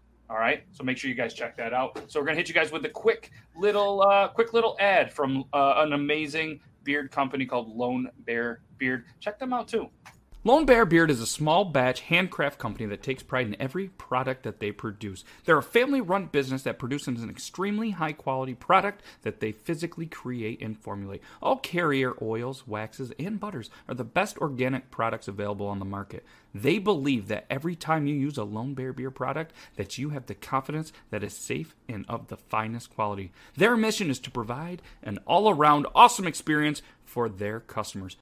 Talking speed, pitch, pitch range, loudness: 195 wpm, 135 Hz, 115-165 Hz, -27 LUFS